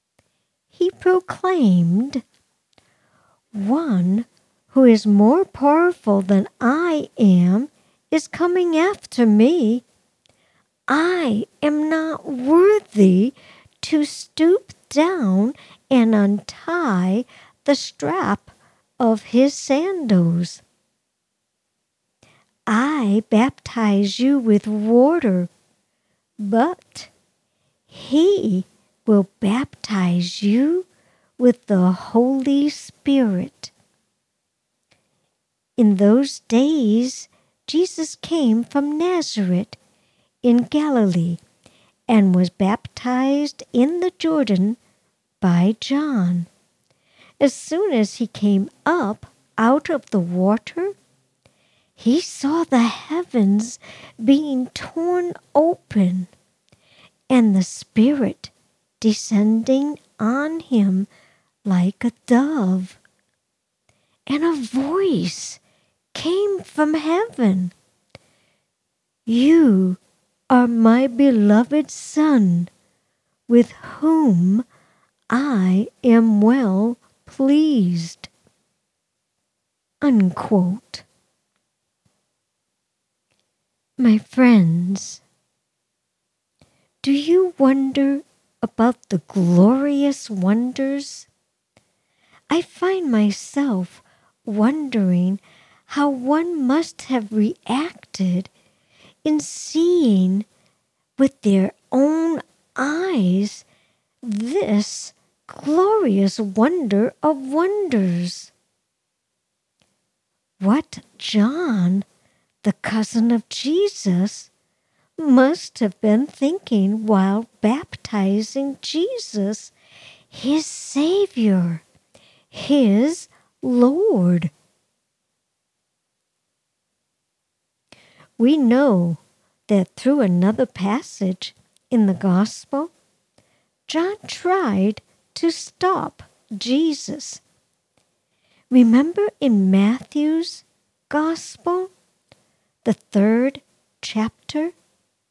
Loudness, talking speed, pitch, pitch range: -19 LUFS, 70 wpm, 240 Hz, 200-295 Hz